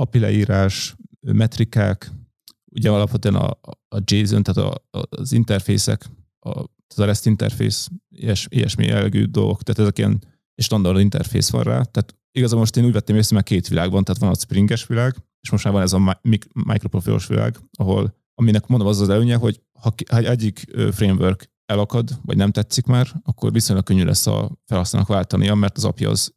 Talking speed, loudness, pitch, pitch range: 185 wpm, -19 LUFS, 110 Hz, 100-120 Hz